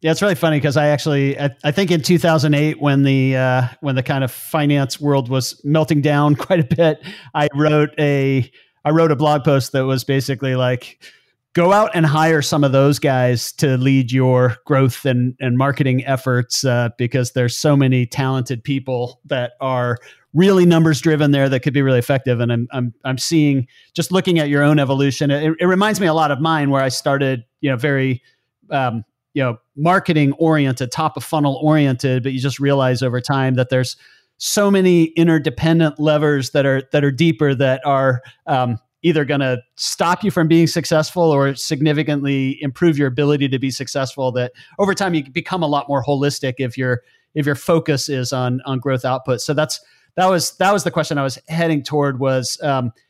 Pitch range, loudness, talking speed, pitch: 130-155 Hz, -17 LUFS, 195 wpm, 140 Hz